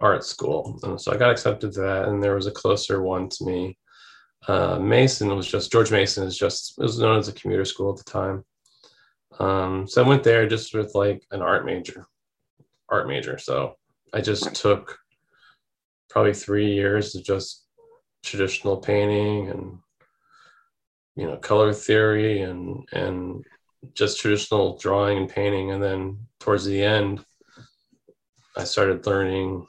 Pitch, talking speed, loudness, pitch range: 100 Hz, 160 wpm, -23 LUFS, 95-105 Hz